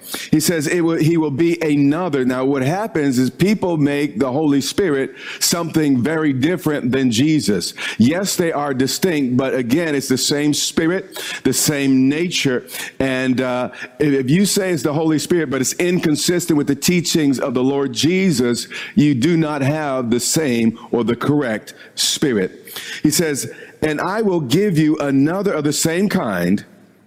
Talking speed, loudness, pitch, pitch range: 170 wpm, -17 LUFS, 150 Hz, 135-170 Hz